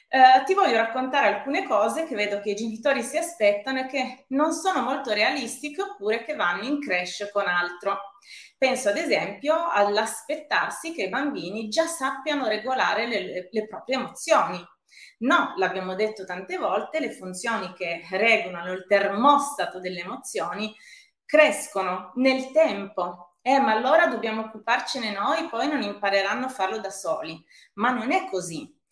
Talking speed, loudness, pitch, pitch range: 150 wpm, -24 LUFS, 225 Hz, 200-280 Hz